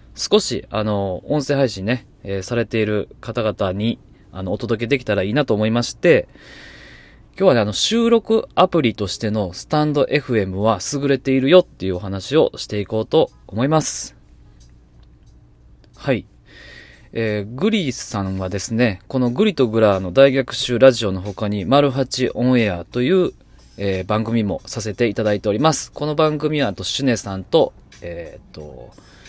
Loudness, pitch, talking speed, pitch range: -19 LUFS, 110 Hz, 325 characters per minute, 100-135 Hz